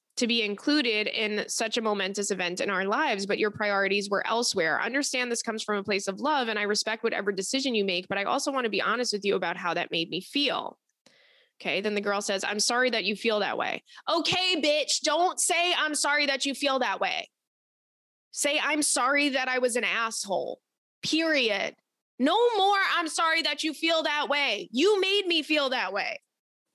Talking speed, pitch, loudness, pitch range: 210 wpm, 245 Hz, -26 LUFS, 205-300 Hz